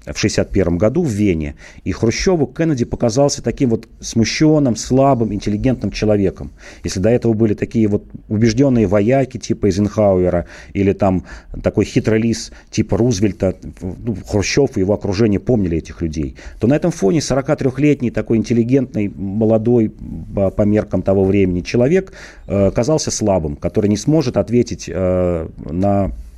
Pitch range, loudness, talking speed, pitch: 95-120 Hz, -17 LUFS, 140 wpm, 105 Hz